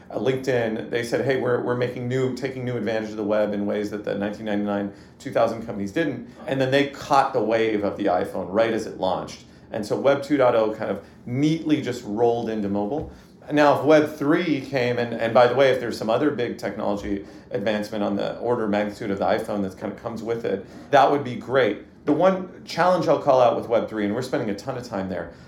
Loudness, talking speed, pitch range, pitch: -23 LUFS, 230 wpm, 105-130 Hz, 115 Hz